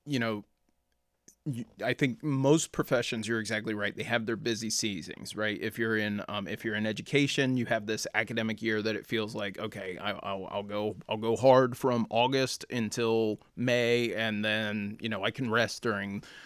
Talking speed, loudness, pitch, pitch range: 190 wpm, -30 LUFS, 110 Hz, 105-120 Hz